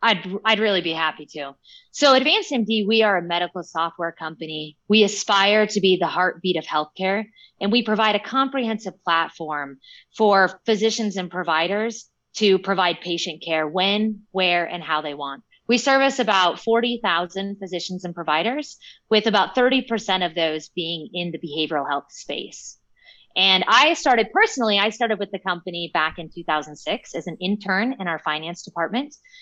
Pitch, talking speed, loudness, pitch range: 190 Hz, 165 wpm, -21 LUFS, 165-220 Hz